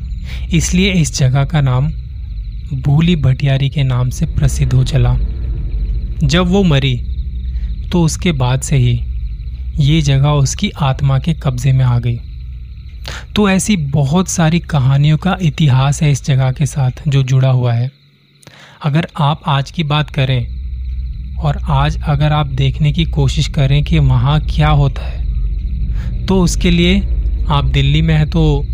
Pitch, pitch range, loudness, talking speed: 135 Hz, 110-150 Hz, -14 LUFS, 150 wpm